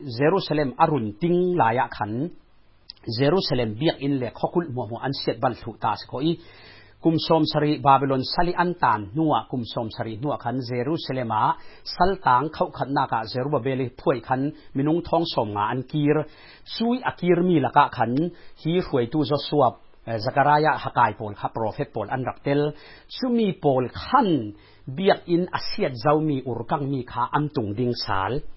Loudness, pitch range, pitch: -24 LUFS, 125-165 Hz, 145 Hz